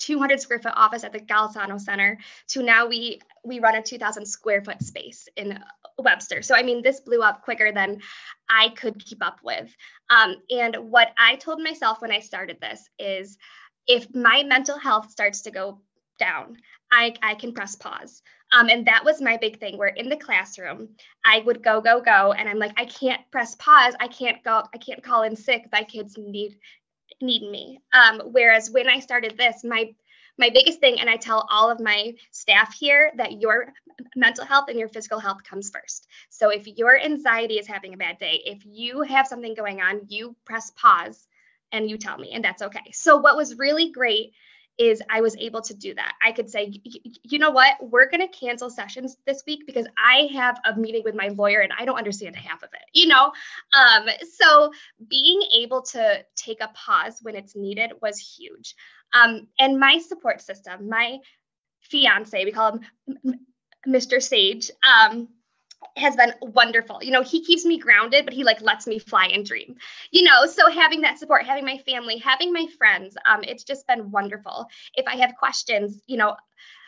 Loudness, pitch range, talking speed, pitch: -19 LUFS, 215-270 Hz, 200 wpm, 235 Hz